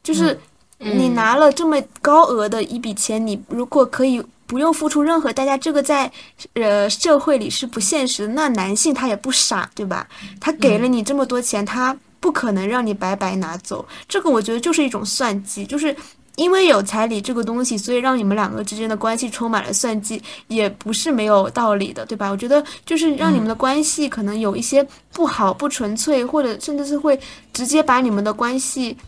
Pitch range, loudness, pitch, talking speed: 215-290 Hz, -18 LUFS, 245 Hz, 305 characters per minute